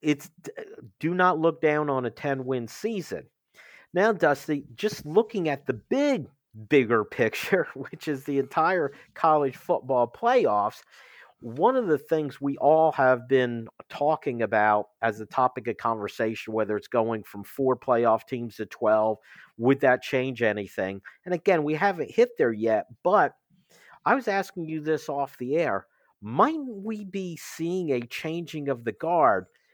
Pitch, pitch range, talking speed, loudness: 140 Hz, 120-180 Hz, 160 wpm, -26 LUFS